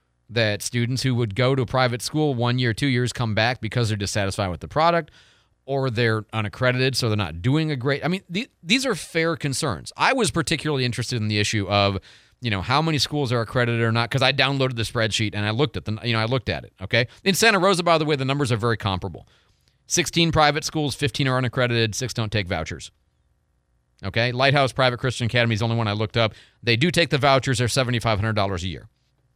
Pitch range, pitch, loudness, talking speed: 110-140 Hz, 120 Hz, -22 LUFS, 235 wpm